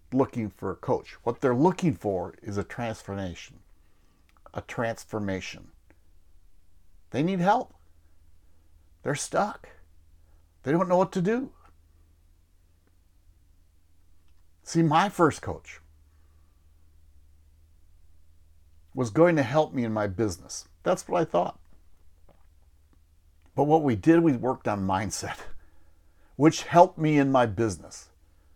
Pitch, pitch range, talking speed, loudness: 80 Hz, 80-115 Hz, 115 wpm, -26 LUFS